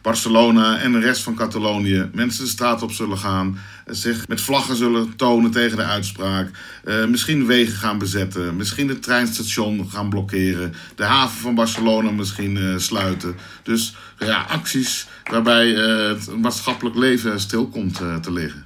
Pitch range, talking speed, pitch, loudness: 100-120 Hz, 150 wpm, 110 Hz, -19 LUFS